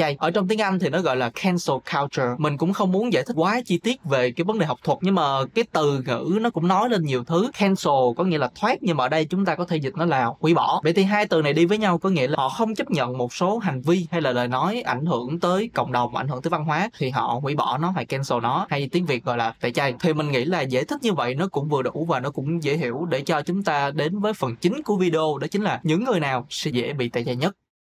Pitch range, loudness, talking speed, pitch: 135-185 Hz, -23 LUFS, 305 wpm, 165 Hz